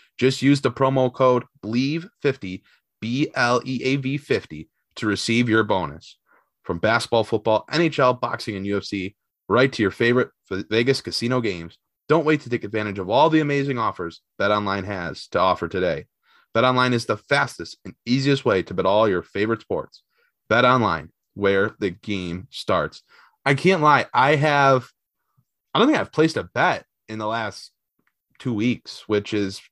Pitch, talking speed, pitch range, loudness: 120 Hz, 170 wpm, 105-135 Hz, -21 LUFS